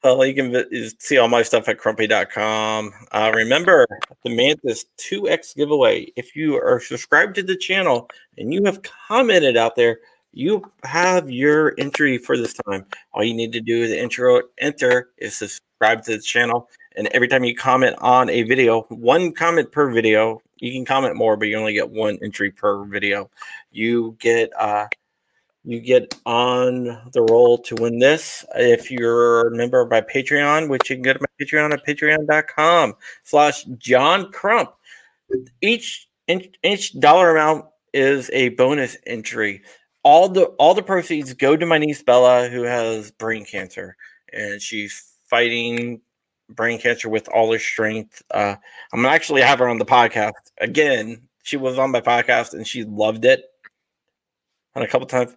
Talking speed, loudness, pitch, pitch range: 170 wpm, -18 LUFS, 125 Hz, 115-150 Hz